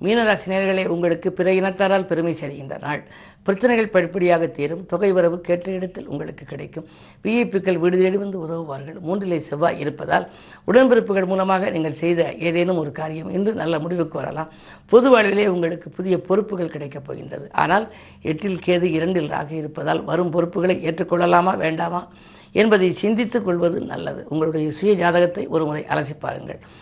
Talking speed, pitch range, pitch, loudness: 135 wpm, 165-195 Hz, 175 Hz, -20 LUFS